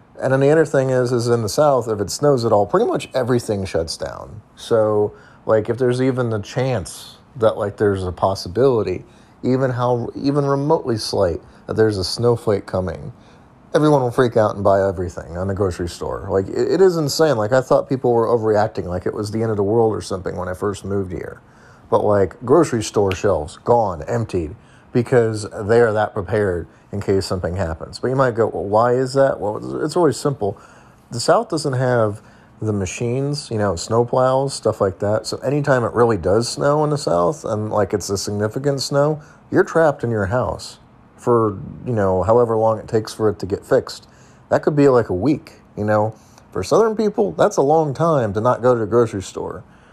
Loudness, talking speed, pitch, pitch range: -19 LUFS, 210 wpm, 115 Hz, 105-135 Hz